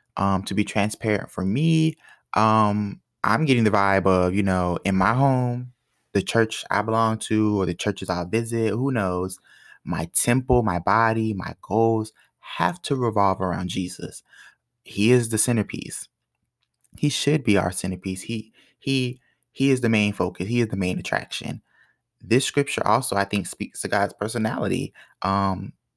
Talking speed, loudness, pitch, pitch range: 165 wpm, -23 LUFS, 105 Hz, 95-120 Hz